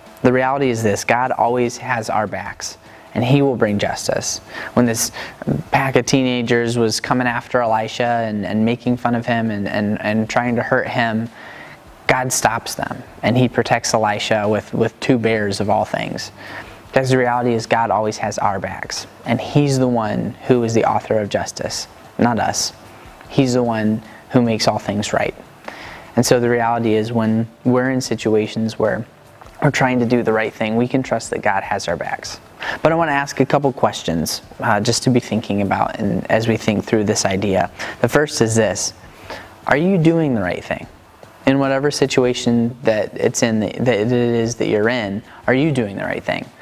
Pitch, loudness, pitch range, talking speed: 120 Hz, -18 LUFS, 110-125 Hz, 195 wpm